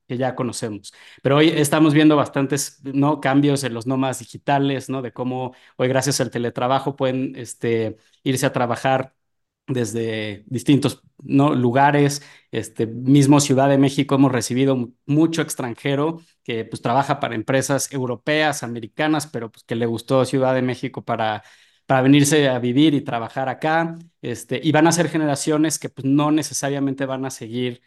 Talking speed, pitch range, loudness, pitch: 160 wpm, 125-145 Hz, -20 LUFS, 135 Hz